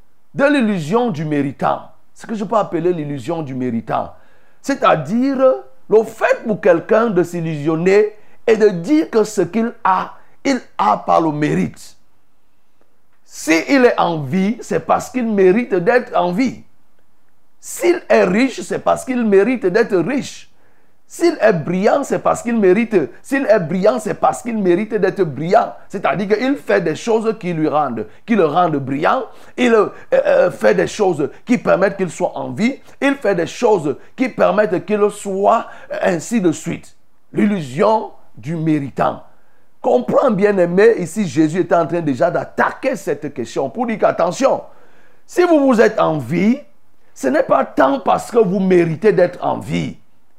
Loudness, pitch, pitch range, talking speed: -16 LUFS, 210 Hz, 175-240 Hz, 165 wpm